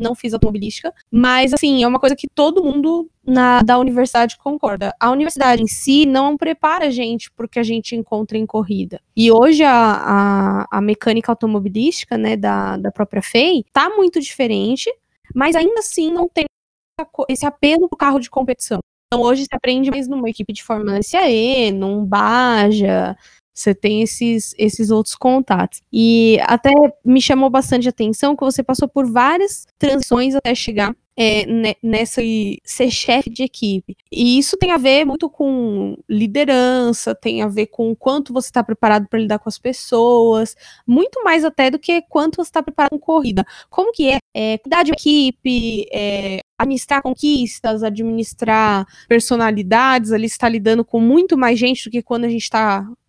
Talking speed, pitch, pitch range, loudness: 175 wpm, 245 Hz, 220-280 Hz, -16 LUFS